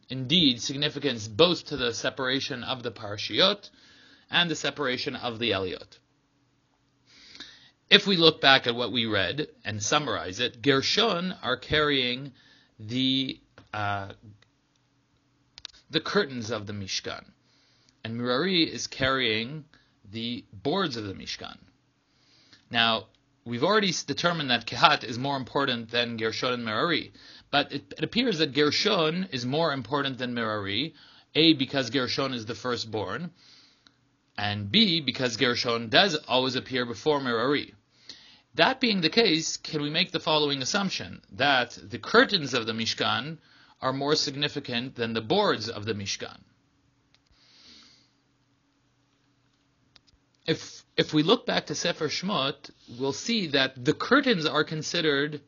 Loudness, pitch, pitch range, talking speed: -26 LUFS, 135 Hz, 120-155 Hz, 135 wpm